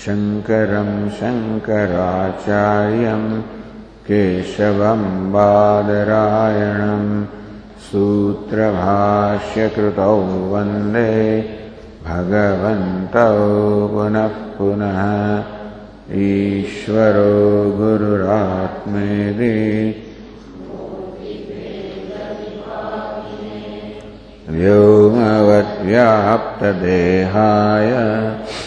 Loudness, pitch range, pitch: -16 LUFS, 100-110 Hz, 105 Hz